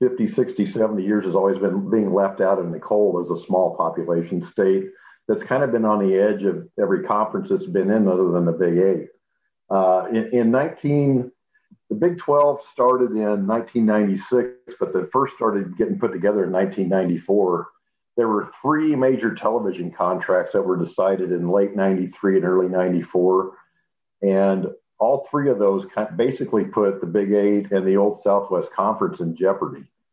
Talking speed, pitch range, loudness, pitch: 175 wpm, 95-115 Hz, -21 LUFS, 100 Hz